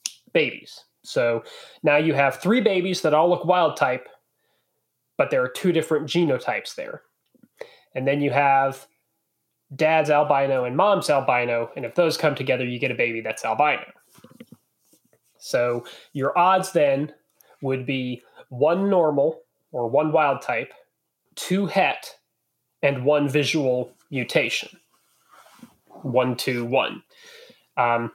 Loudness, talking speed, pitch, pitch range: -22 LUFS, 130 wpm, 145 Hz, 130-175 Hz